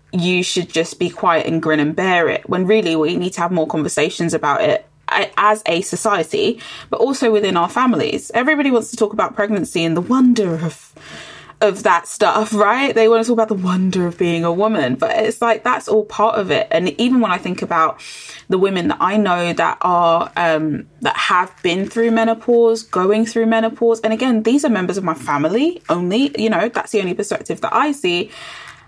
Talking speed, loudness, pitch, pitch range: 210 wpm, -17 LUFS, 210 Hz, 175-225 Hz